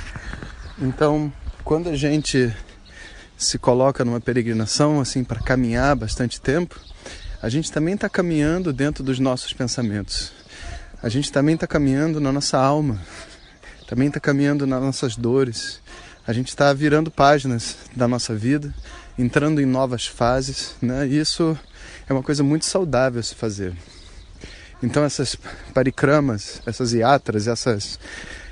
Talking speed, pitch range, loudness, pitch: 135 wpm, 120-145 Hz, -21 LUFS, 130 Hz